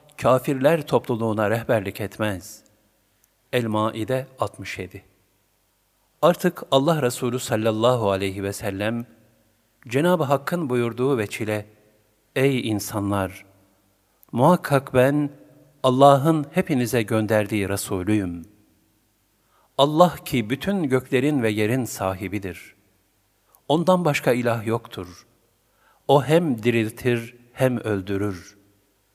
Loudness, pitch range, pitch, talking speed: -22 LUFS, 100-130 Hz, 115 Hz, 85 wpm